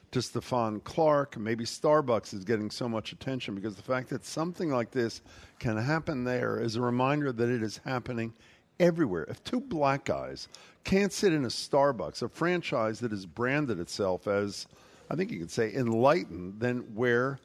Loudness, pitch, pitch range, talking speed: -30 LUFS, 120 Hz, 110-140 Hz, 180 wpm